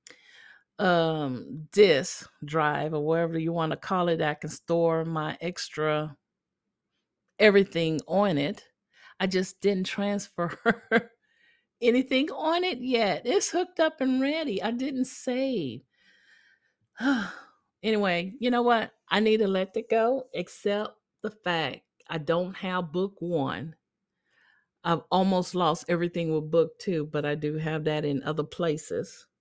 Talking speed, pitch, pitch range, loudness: 135 wpm, 185 Hz, 160-230 Hz, -27 LUFS